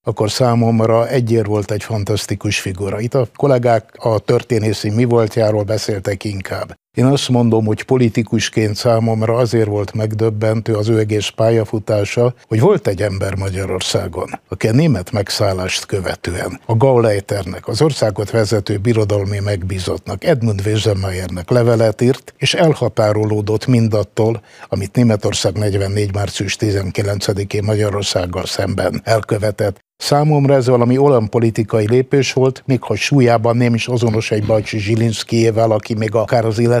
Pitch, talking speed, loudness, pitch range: 110 Hz, 135 wpm, -16 LUFS, 105-120 Hz